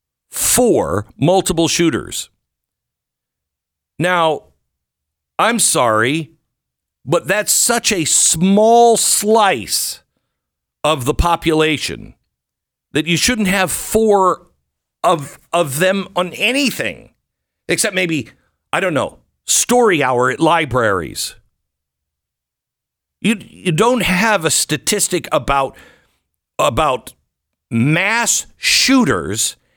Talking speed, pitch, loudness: 90 wpm, 165 Hz, -15 LUFS